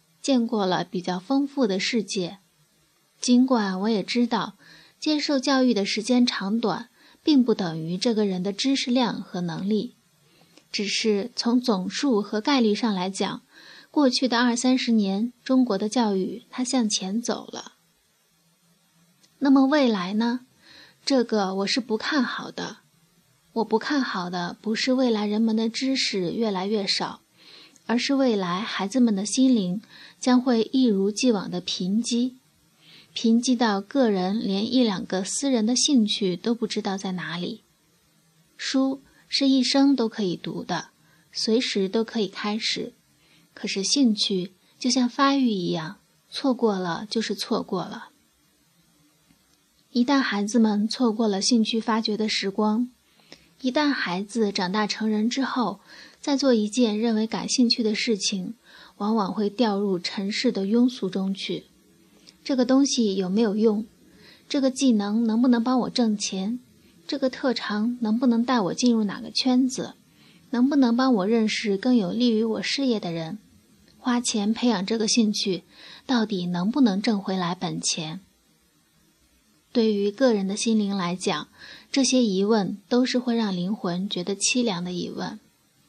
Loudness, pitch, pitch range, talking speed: -24 LUFS, 220 Hz, 195-245 Hz, 220 characters per minute